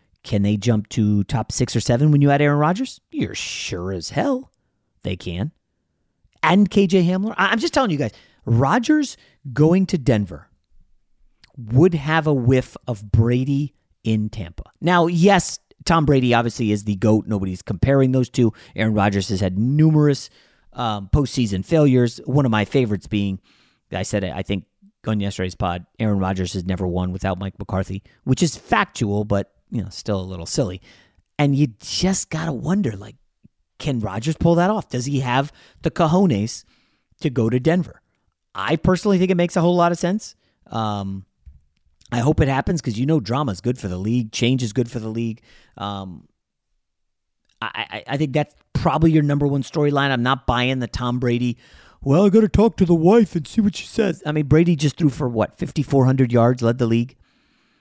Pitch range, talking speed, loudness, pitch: 105-155 Hz, 190 wpm, -20 LUFS, 125 Hz